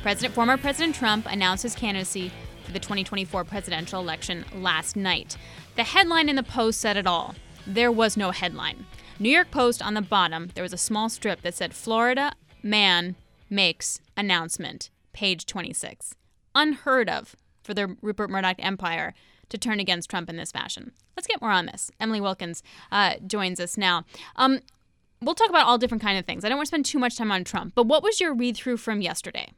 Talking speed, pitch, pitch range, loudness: 195 wpm, 210 Hz, 185-245 Hz, -24 LUFS